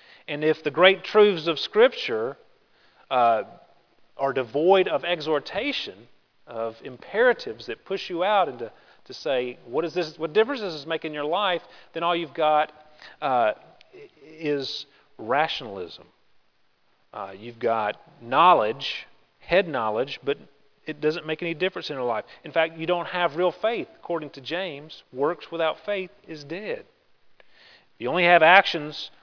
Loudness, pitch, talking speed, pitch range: -24 LUFS, 165 Hz, 150 wpm, 150-185 Hz